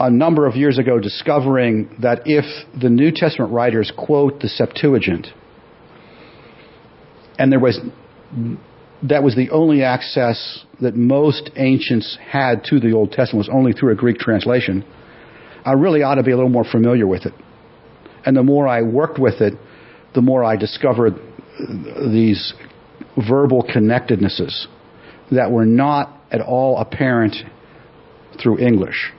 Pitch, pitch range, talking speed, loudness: 125 Hz, 115-140 Hz, 145 wpm, -16 LUFS